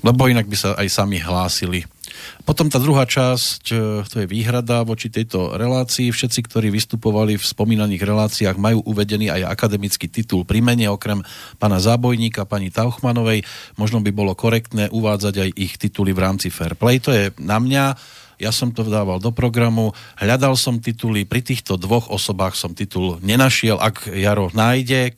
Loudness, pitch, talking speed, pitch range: -18 LUFS, 110 Hz, 165 wpm, 100-120 Hz